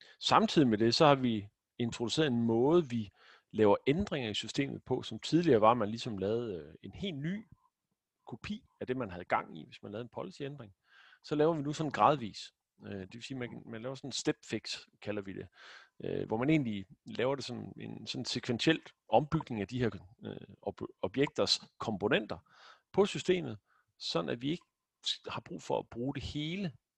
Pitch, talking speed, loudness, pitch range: 125 Hz, 185 wpm, -33 LUFS, 110-150 Hz